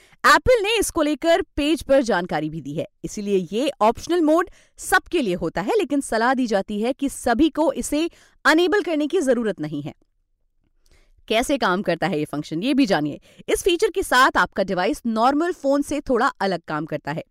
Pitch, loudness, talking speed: 255 Hz, -21 LUFS, 195 wpm